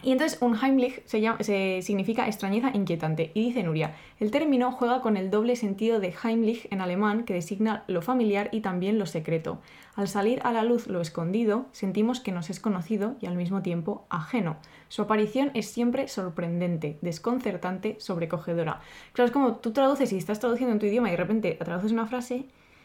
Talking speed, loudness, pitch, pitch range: 190 wpm, -28 LUFS, 215 Hz, 180-240 Hz